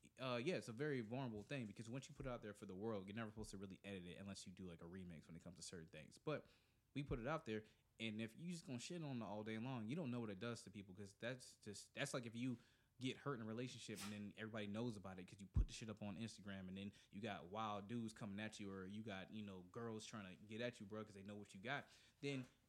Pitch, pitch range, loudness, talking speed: 110 Hz, 100-120 Hz, -51 LUFS, 305 wpm